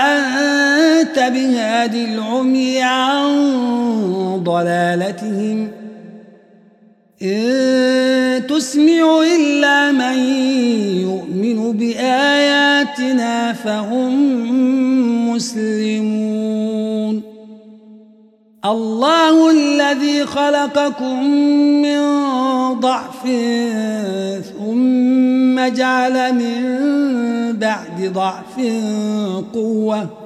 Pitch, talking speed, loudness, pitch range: 245 Hz, 45 wpm, -16 LUFS, 215-265 Hz